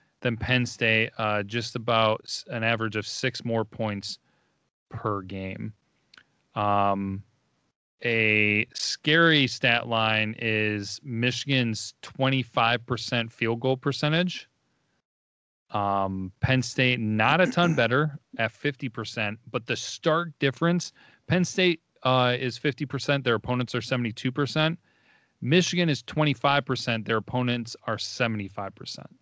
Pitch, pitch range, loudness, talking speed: 120 Hz, 110-140 Hz, -25 LUFS, 110 wpm